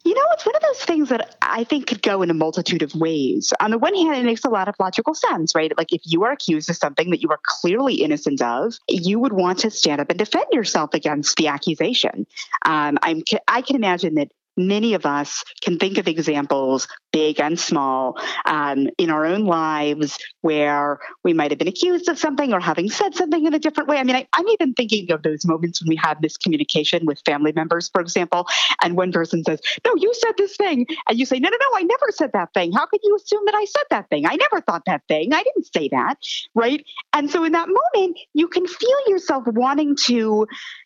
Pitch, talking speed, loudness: 205 Hz, 235 wpm, -20 LUFS